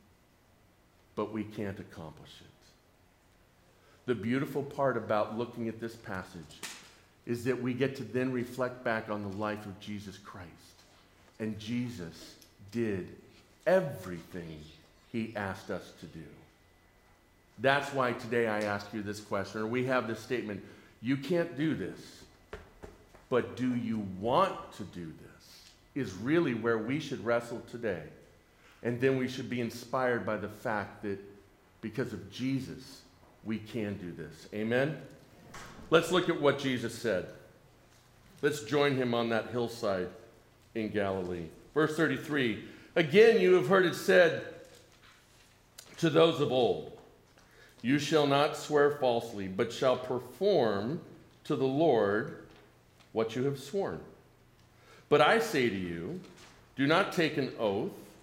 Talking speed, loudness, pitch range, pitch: 140 wpm, -31 LUFS, 100-135 Hz, 115 Hz